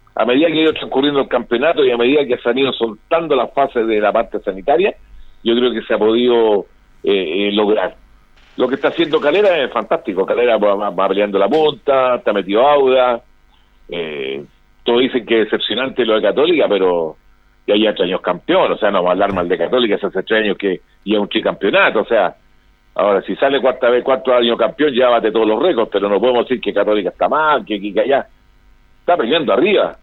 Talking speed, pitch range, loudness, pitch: 220 wpm, 105-130 Hz, -15 LUFS, 120 Hz